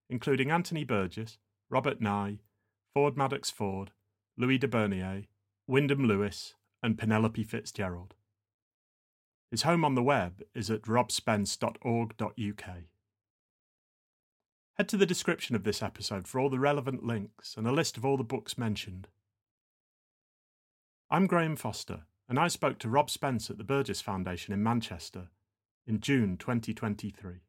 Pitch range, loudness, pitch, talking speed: 100-130 Hz, -31 LUFS, 110 Hz, 135 wpm